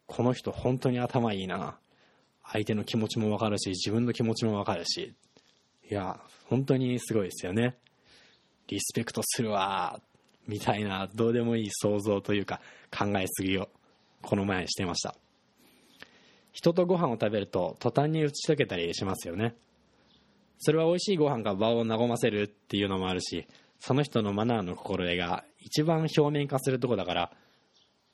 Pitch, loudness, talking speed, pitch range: 110 Hz, -30 LUFS, 335 characters per minute, 100-125 Hz